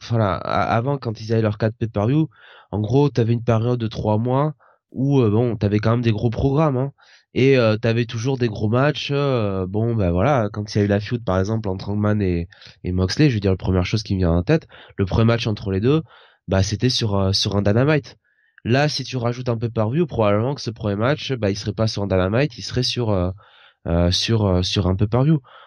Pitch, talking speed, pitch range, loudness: 115 Hz, 250 wpm, 100-125 Hz, -20 LUFS